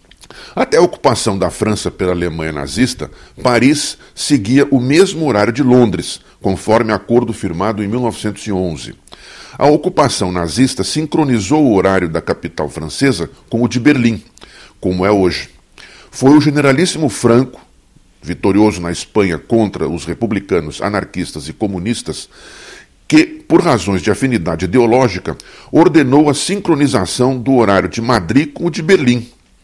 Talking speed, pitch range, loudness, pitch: 135 wpm, 95-140 Hz, -14 LUFS, 115 Hz